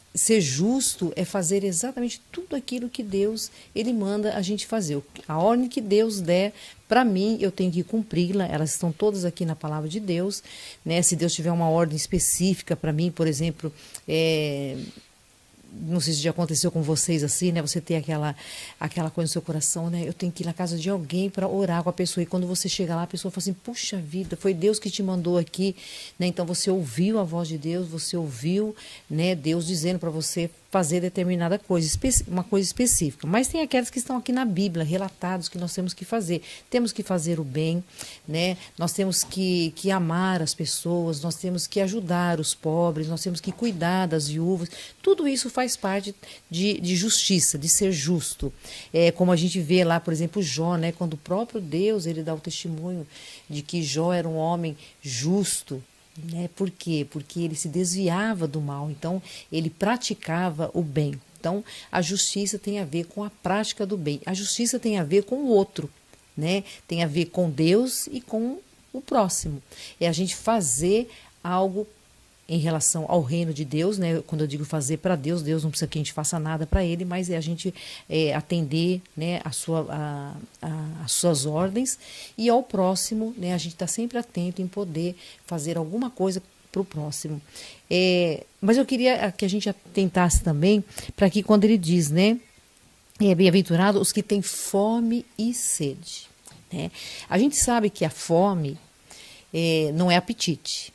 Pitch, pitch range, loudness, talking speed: 180 Hz, 165-200 Hz, -25 LUFS, 195 wpm